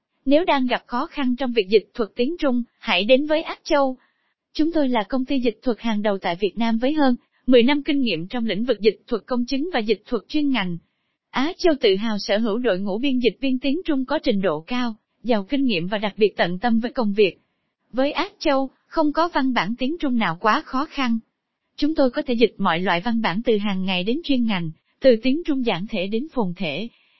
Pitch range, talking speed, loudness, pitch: 215-275 Hz, 245 wpm, -22 LUFS, 245 Hz